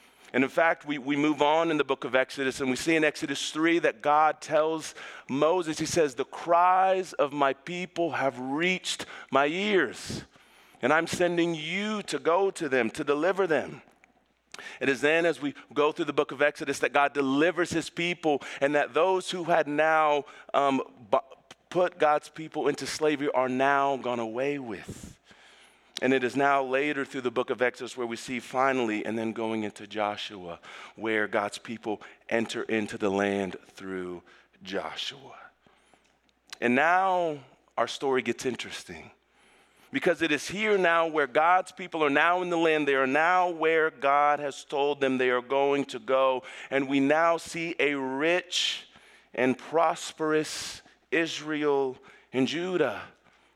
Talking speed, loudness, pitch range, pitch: 165 wpm, -27 LUFS, 130-165 Hz, 145 Hz